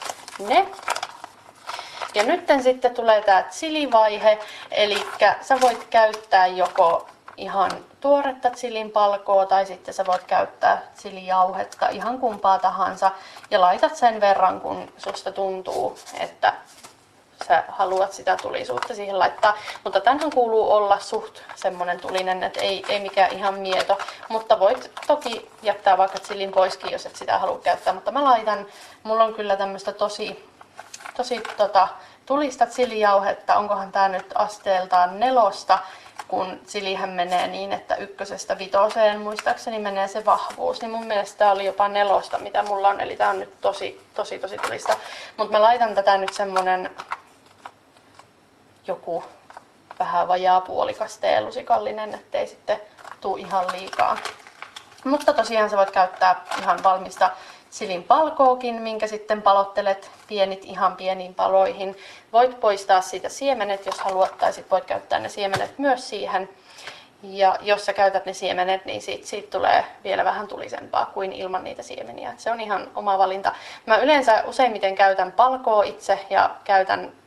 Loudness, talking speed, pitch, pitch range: -22 LUFS, 145 wpm, 205 Hz, 190-230 Hz